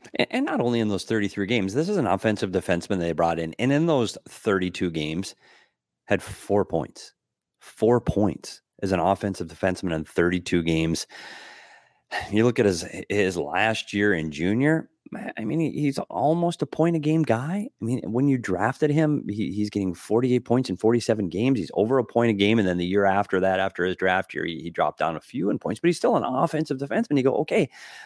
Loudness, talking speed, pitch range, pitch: -24 LUFS, 205 wpm, 95-135 Hz, 105 Hz